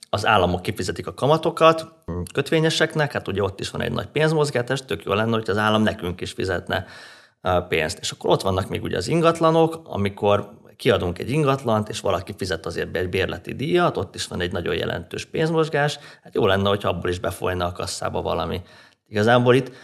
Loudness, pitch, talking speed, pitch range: -22 LUFS, 110 Hz, 190 wpm, 95-150 Hz